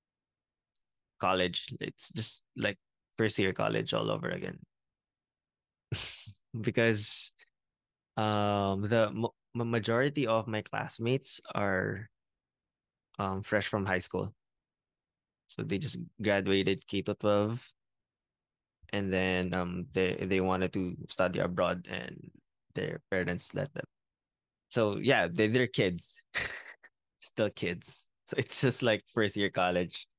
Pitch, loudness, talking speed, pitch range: 100 Hz, -32 LUFS, 115 wpm, 95-110 Hz